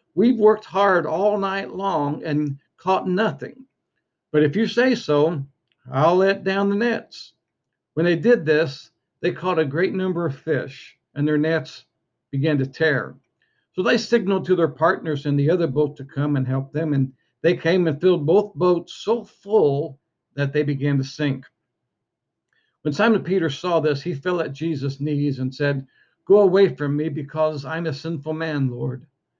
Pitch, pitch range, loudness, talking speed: 160 Hz, 145-185 Hz, -21 LUFS, 180 wpm